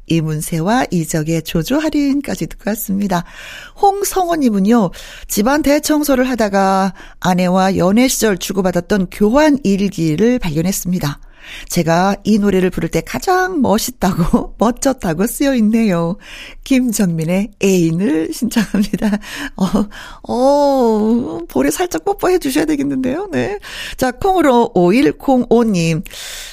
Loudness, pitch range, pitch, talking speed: -15 LUFS, 180-265 Hz, 210 Hz, 260 characters per minute